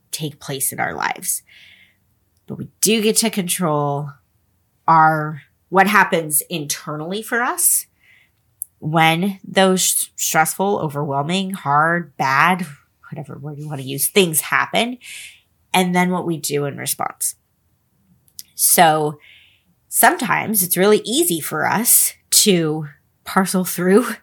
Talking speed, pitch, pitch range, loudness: 120 wpm, 160 Hz, 145-190 Hz, -17 LUFS